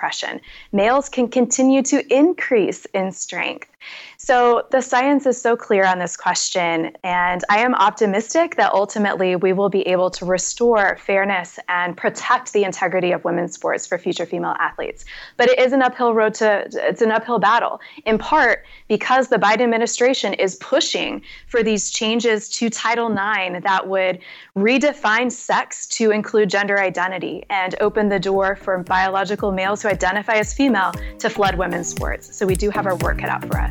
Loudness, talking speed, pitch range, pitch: -19 LUFS, 175 wpm, 190-240 Hz, 210 Hz